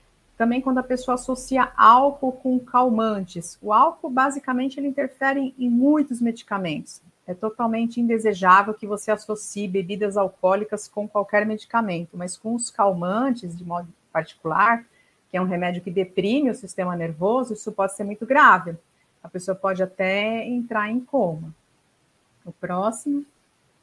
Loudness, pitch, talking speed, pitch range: -22 LUFS, 210 Hz, 145 wpm, 185-250 Hz